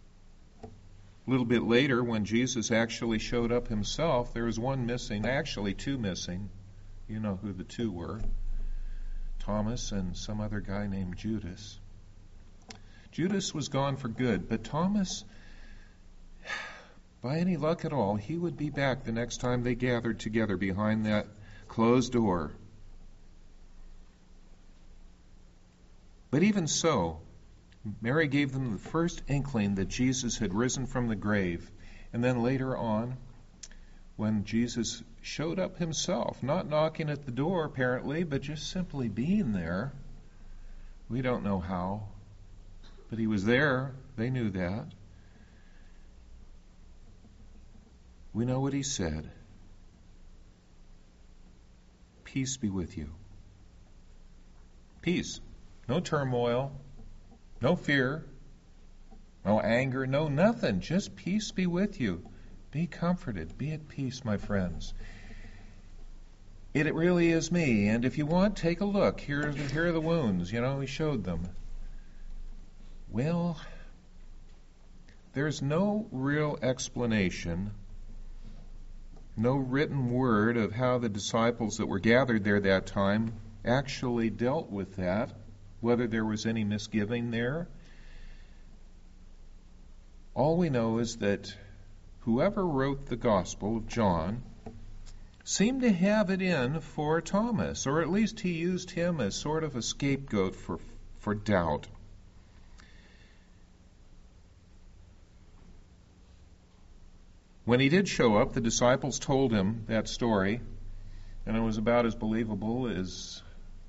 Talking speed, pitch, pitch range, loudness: 125 wpm, 110 Hz, 95-135 Hz, -30 LUFS